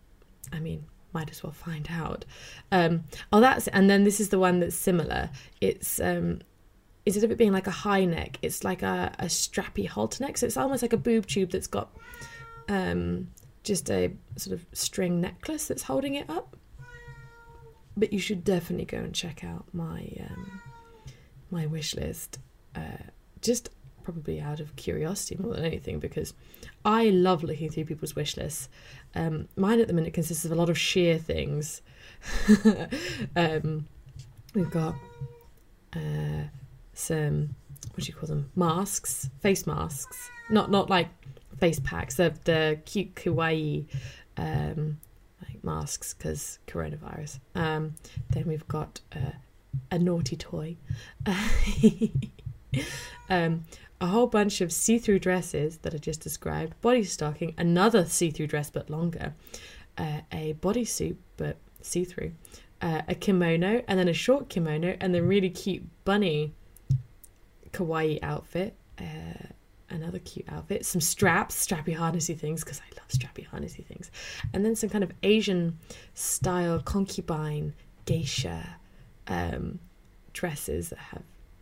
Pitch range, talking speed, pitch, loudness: 140-190 Hz, 150 wpm, 165 Hz, -28 LUFS